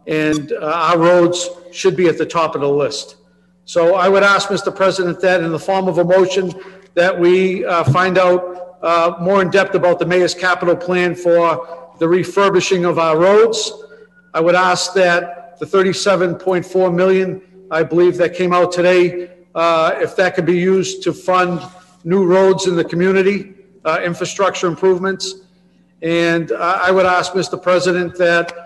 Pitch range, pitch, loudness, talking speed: 175-190 Hz, 180 Hz, -15 LUFS, 170 wpm